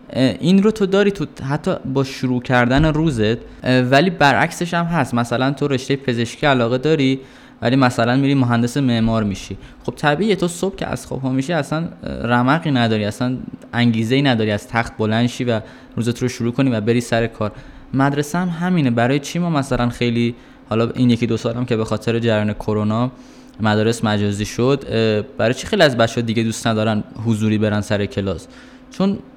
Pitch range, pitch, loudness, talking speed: 115-140 Hz, 125 Hz, -18 LUFS, 180 wpm